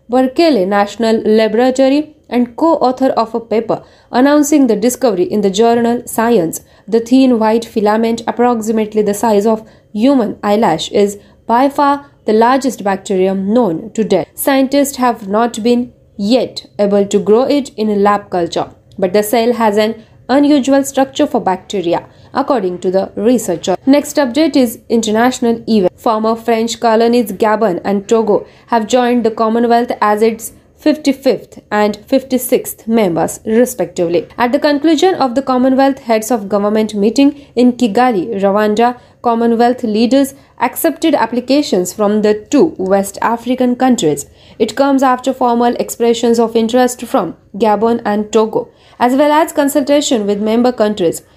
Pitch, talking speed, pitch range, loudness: 235 Hz, 145 wpm, 210-260 Hz, -13 LUFS